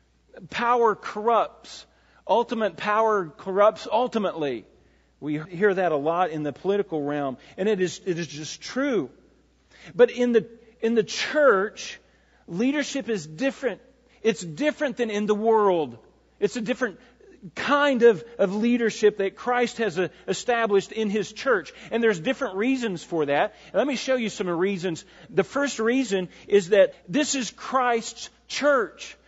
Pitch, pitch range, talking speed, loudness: 215 Hz, 185-245 Hz, 150 wpm, -24 LUFS